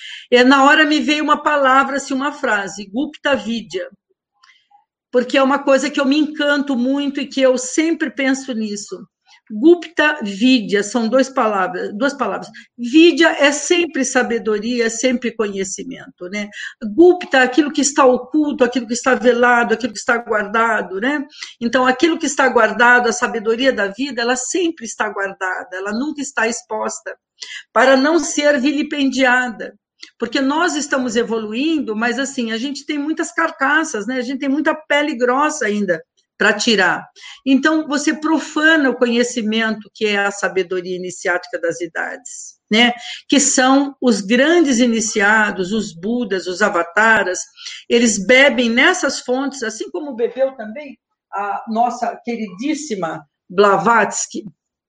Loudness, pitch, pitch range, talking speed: -16 LUFS, 250 Hz, 220-290 Hz, 140 wpm